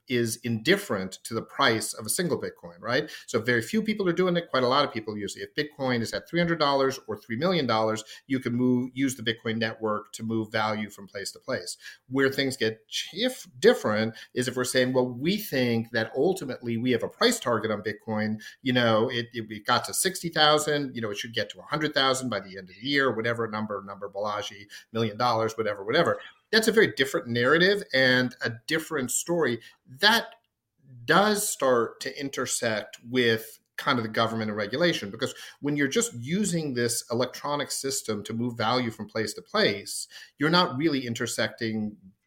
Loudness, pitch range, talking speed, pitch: -26 LUFS, 110-140 Hz, 200 wpm, 120 Hz